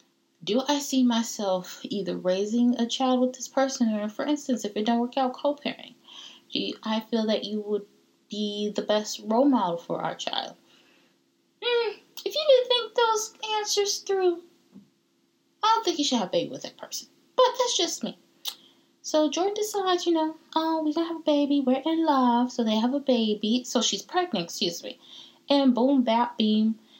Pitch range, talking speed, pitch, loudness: 225-335 Hz, 185 wpm, 260 Hz, -26 LUFS